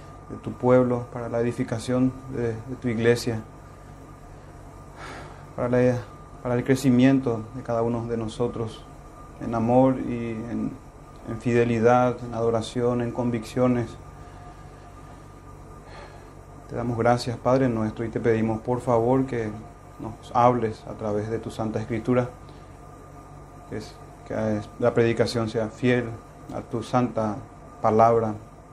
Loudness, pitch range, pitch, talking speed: -24 LUFS, 115-125 Hz, 120 Hz, 125 wpm